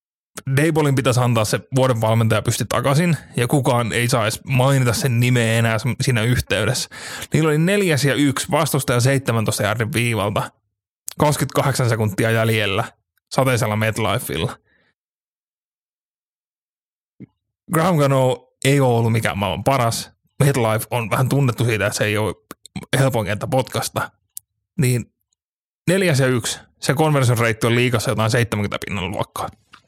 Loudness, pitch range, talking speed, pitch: -19 LUFS, 110-135 Hz, 130 wpm, 120 Hz